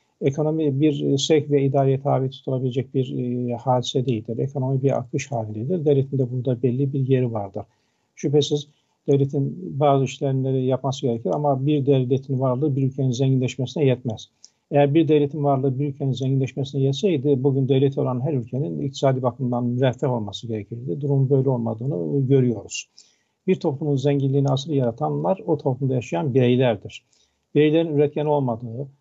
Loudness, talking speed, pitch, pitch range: -22 LUFS, 145 wpm, 135 Hz, 130-145 Hz